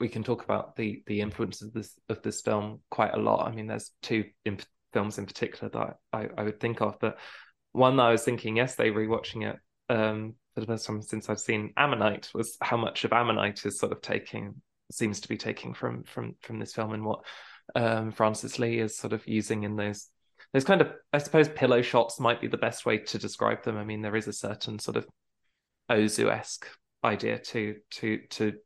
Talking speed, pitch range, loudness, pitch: 220 wpm, 105-115 Hz, -29 LUFS, 110 Hz